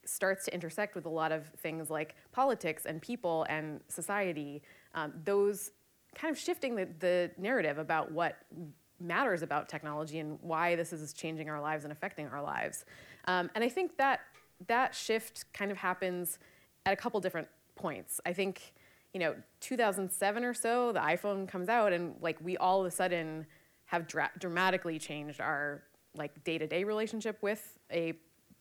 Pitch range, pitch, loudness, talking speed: 155-200 Hz, 175 Hz, -35 LUFS, 170 wpm